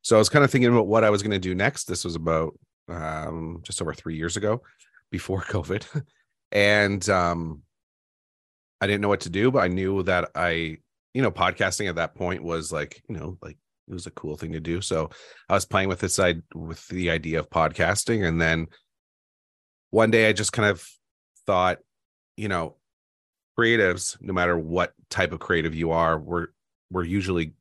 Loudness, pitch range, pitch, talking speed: -24 LUFS, 80-100 Hz, 85 Hz, 200 wpm